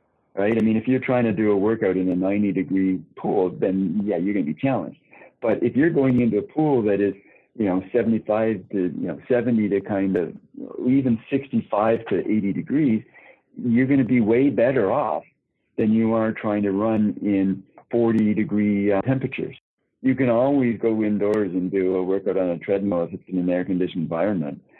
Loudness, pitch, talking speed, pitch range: -22 LUFS, 105 Hz, 200 wpm, 95-115 Hz